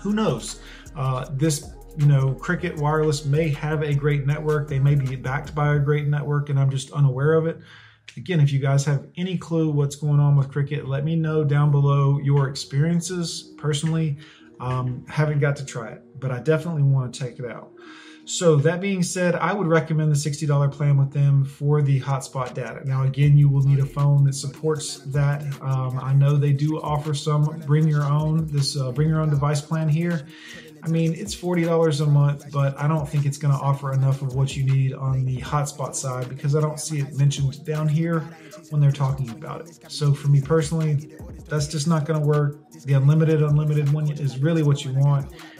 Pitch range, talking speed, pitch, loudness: 140-155 Hz, 210 wpm, 145 Hz, -22 LUFS